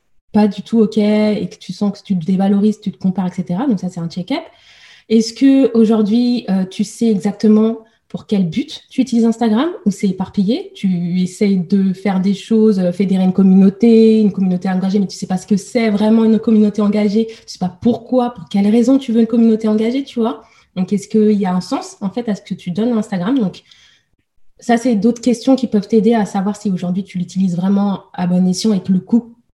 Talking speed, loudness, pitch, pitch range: 230 wpm, -15 LUFS, 210 Hz, 190-230 Hz